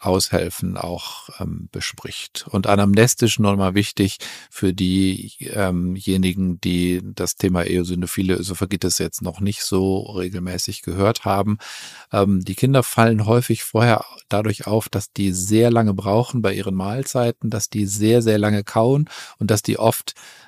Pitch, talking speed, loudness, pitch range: 100 Hz, 145 wpm, -20 LUFS, 95-110 Hz